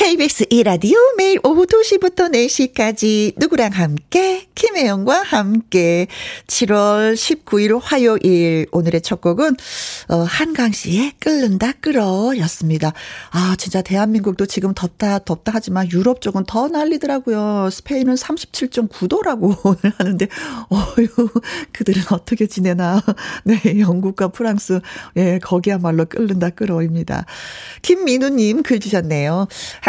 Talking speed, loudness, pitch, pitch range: 270 characters per minute, -16 LUFS, 215 Hz, 185-255 Hz